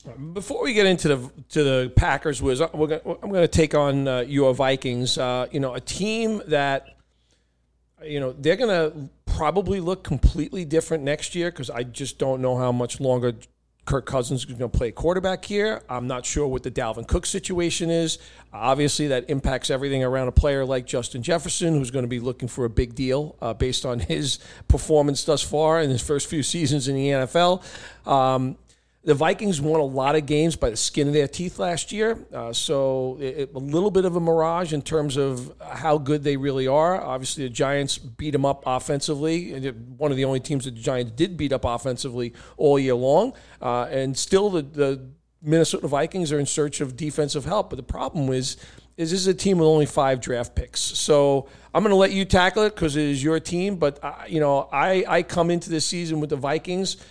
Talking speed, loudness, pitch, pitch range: 215 wpm, -23 LUFS, 145 Hz, 130-160 Hz